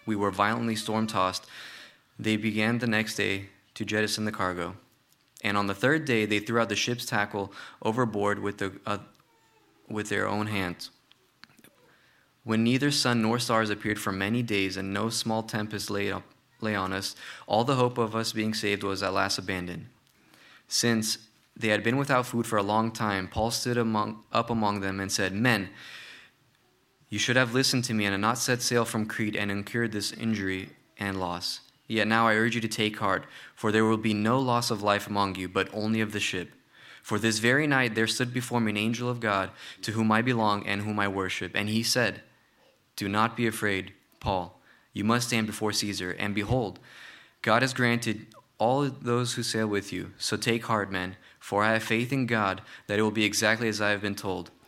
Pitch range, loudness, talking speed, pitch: 100-115 Hz, -28 LUFS, 205 wpm, 110 Hz